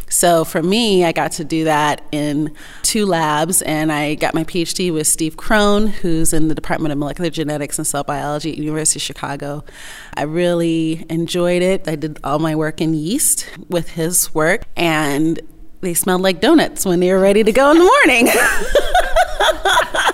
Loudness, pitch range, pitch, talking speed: -16 LUFS, 155-180 Hz, 160 Hz, 180 wpm